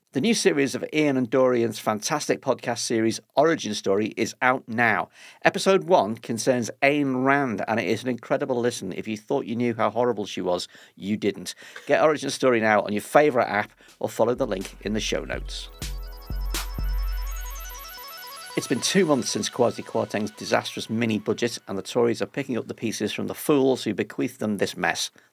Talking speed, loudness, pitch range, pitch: 185 wpm, -24 LUFS, 105-135 Hz, 120 Hz